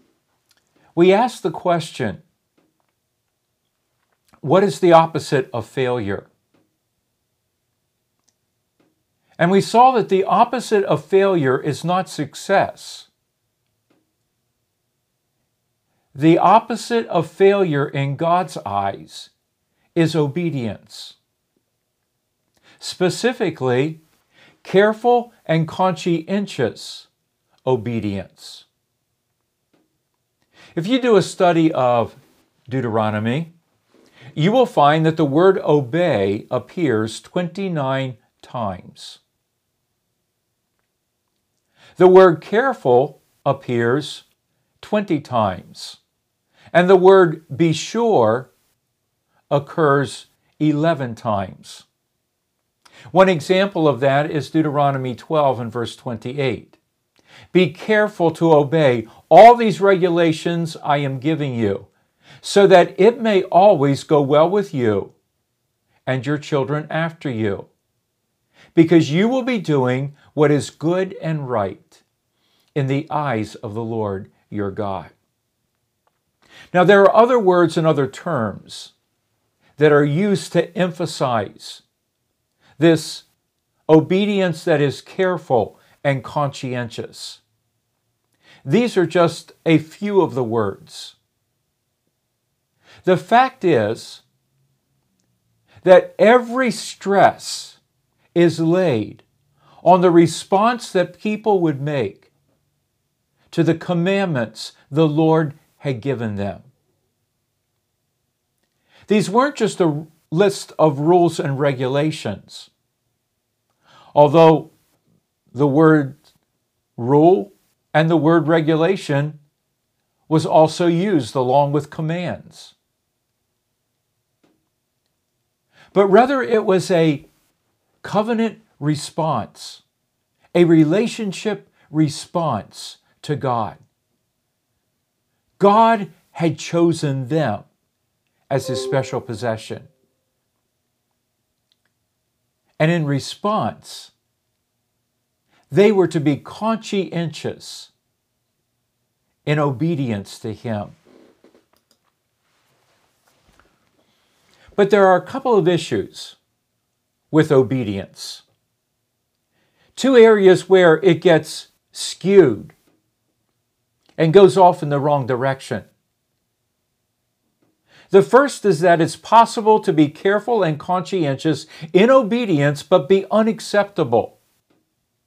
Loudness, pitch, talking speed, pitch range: -17 LUFS, 150 Hz, 90 wpm, 125-180 Hz